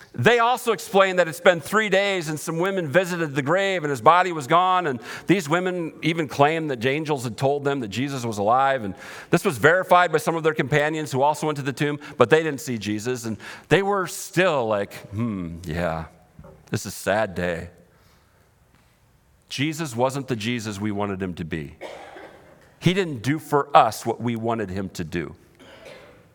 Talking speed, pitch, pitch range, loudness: 195 wpm, 145 Hz, 110-165 Hz, -22 LUFS